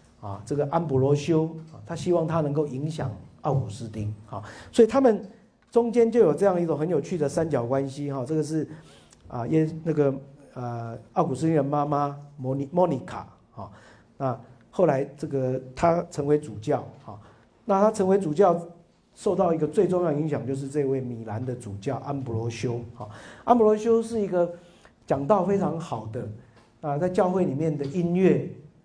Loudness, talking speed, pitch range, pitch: -25 LUFS, 255 characters per minute, 130-175 Hz, 145 Hz